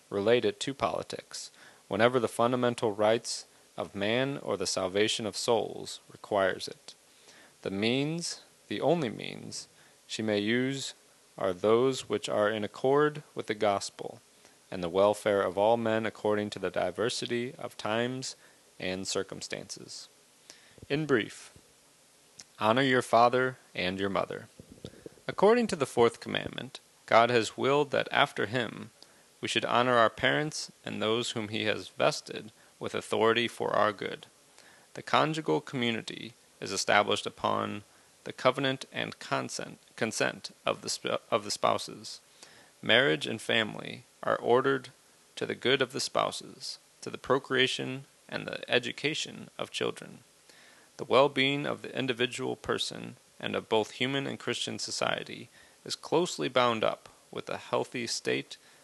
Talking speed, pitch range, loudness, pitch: 145 wpm, 105-135 Hz, -30 LUFS, 120 Hz